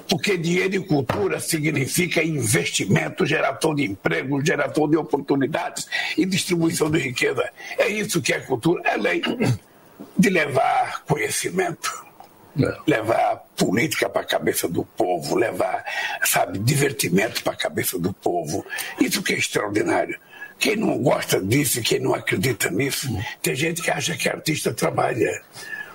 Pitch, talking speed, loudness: 175 Hz, 140 wpm, -22 LUFS